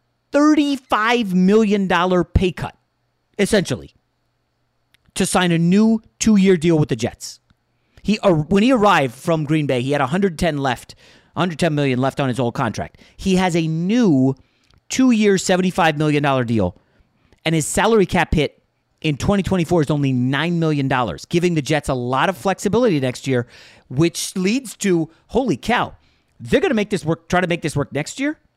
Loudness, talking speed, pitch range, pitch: -18 LUFS, 170 wpm, 135-195 Hz, 165 Hz